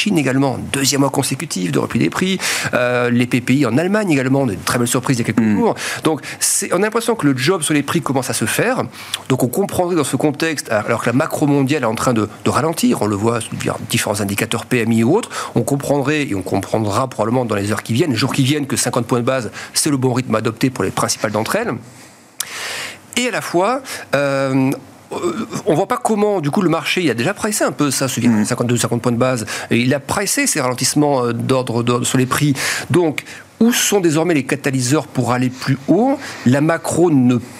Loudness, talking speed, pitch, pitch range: -17 LUFS, 230 wpm, 130 Hz, 120-150 Hz